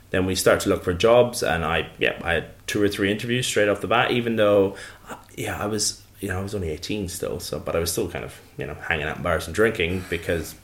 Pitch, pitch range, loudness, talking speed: 100 Hz, 90-105 Hz, -23 LUFS, 270 wpm